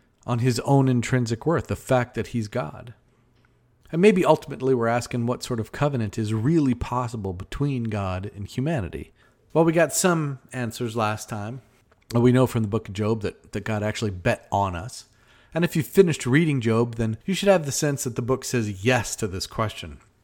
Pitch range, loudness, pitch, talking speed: 110-130 Hz, -24 LUFS, 120 Hz, 200 wpm